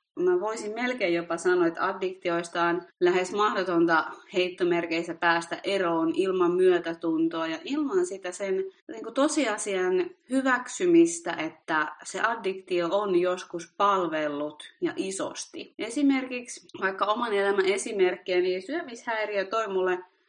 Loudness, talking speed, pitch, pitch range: -27 LUFS, 120 wpm, 185 Hz, 170-220 Hz